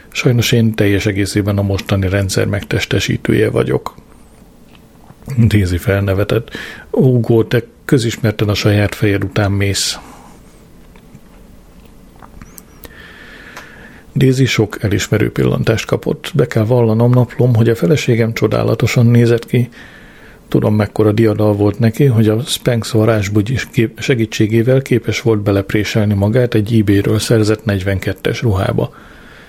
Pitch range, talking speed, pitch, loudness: 105-120 Hz, 110 wpm, 110 Hz, -14 LUFS